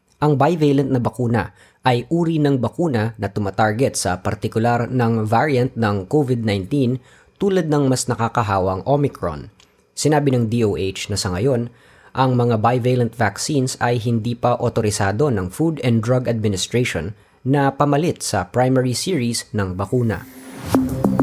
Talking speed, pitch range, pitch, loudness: 135 wpm, 110-130 Hz, 120 Hz, -19 LUFS